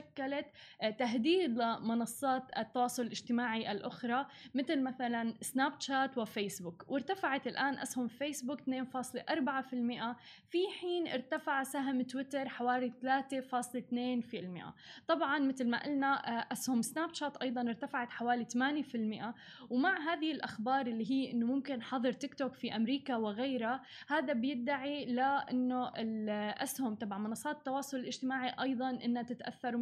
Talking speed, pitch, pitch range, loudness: 115 wpm, 255 Hz, 240-275 Hz, -36 LUFS